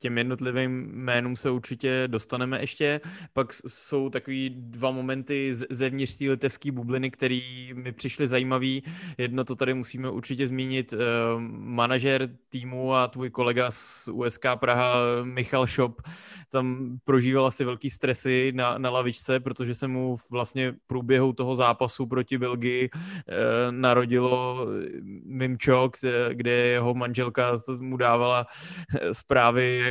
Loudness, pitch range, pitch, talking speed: -26 LUFS, 125-130 Hz, 130 Hz, 130 wpm